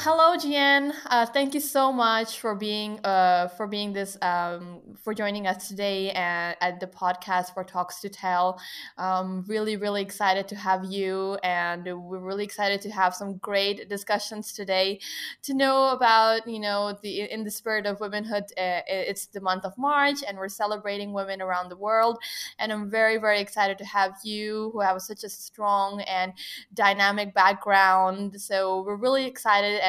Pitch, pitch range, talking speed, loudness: 200 Hz, 190-215 Hz, 175 wpm, -25 LUFS